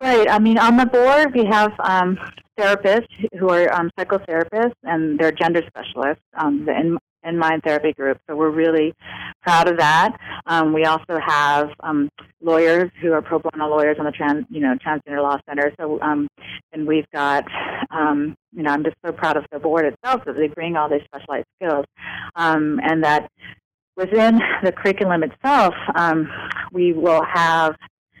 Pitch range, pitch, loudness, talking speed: 150-185 Hz, 160 Hz, -19 LUFS, 180 wpm